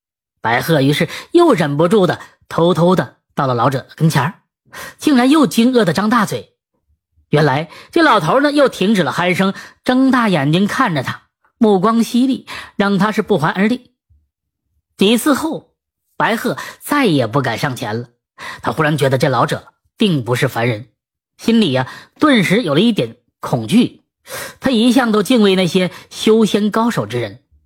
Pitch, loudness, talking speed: 185 Hz, -15 LUFS, 235 characters per minute